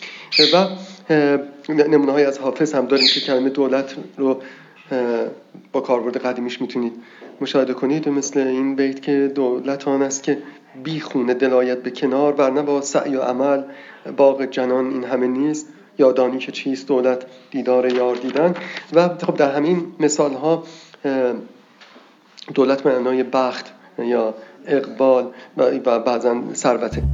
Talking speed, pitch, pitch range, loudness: 135 wpm, 135 Hz, 130-145 Hz, -19 LUFS